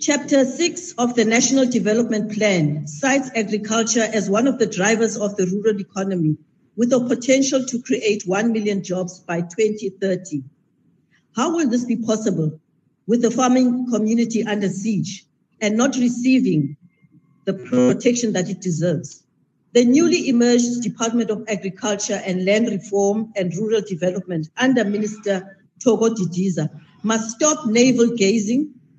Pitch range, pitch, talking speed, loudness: 185-240 Hz, 215 Hz, 140 wpm, -20 LUFS